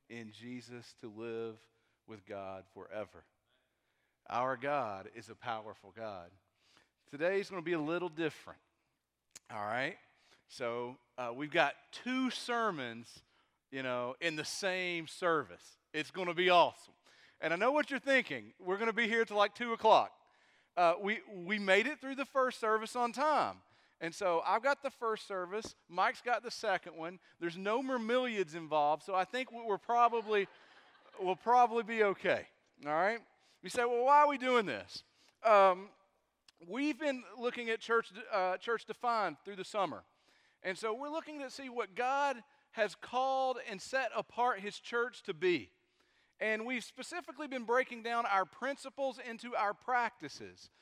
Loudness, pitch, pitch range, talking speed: -35 LUFS, 215 Hz, 170-250 Hz, 165 wpm